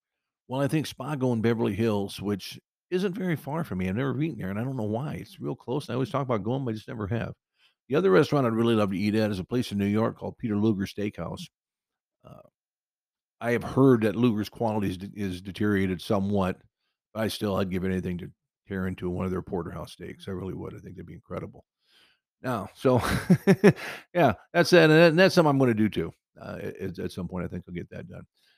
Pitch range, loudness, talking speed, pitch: 100-135 Hz, -26 LUFS, 235 wpm, 110 Hz